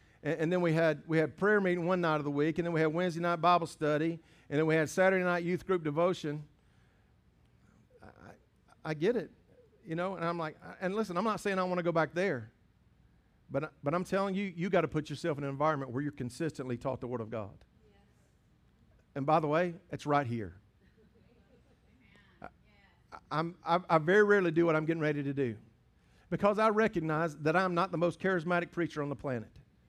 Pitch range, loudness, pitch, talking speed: 145-175 Hz, -32 LUFS, 160 Hz, 210 wpm